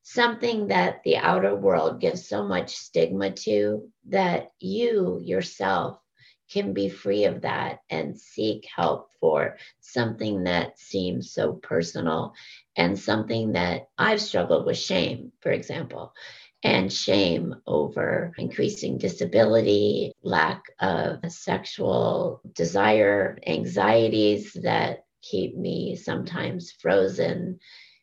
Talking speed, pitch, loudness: 110 wpm, 105 Hz, -25 LUFS